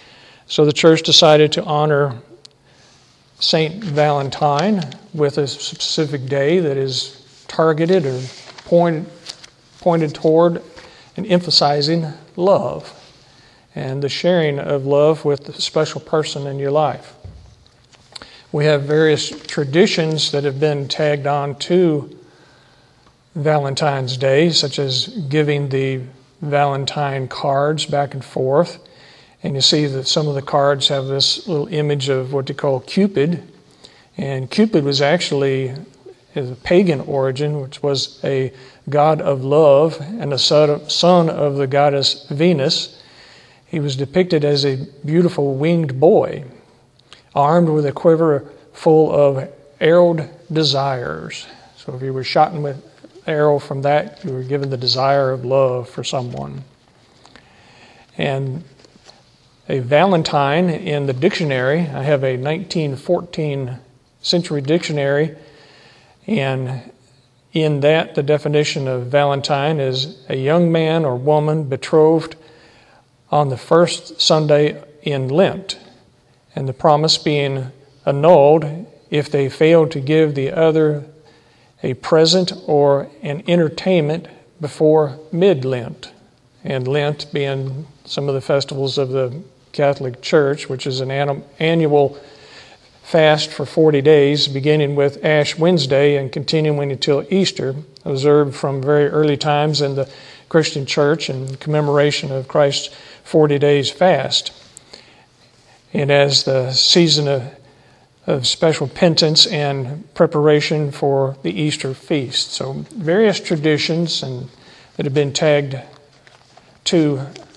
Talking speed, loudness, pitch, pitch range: 125 wpm, -17 LUFS, 145 Hz, 135-160 Hz